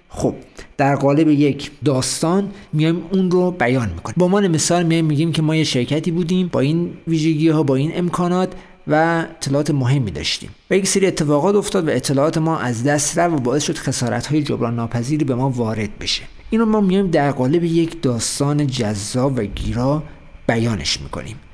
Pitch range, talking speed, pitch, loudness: 130-170 Hz, 180 wpm, 150 Hz, -18 LUFS